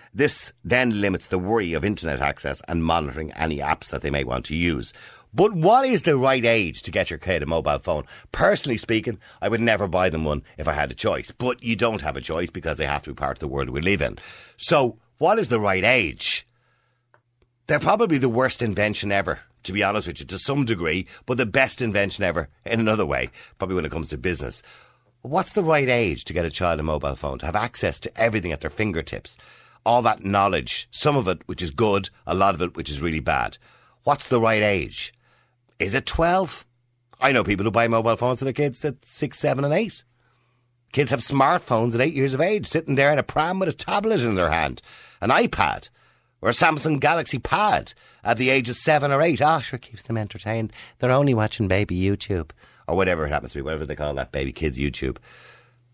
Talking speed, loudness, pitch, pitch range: 225 wpm, -23 LUFS, 110 Hz, 85-130 Hz